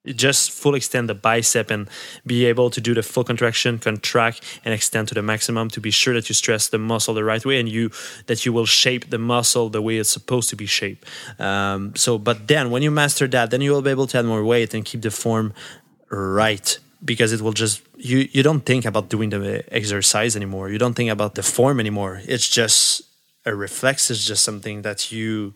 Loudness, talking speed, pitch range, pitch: -19 LUFS, 225 wpm, 110-125 Hz, 115 Hz